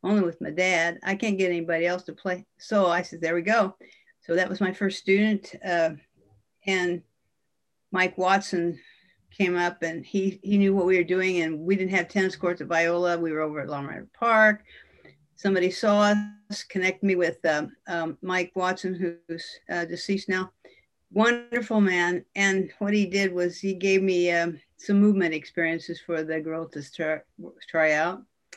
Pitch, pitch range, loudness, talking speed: 185 Hz, 170-195 Hz, -25 LUFS, 180 wpm